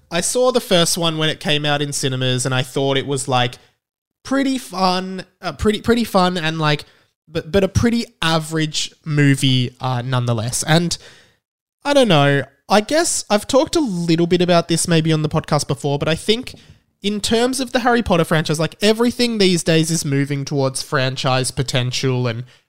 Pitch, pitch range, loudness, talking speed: 160 Hz, 140-195 Hz, -18 LUFS, 190 wpm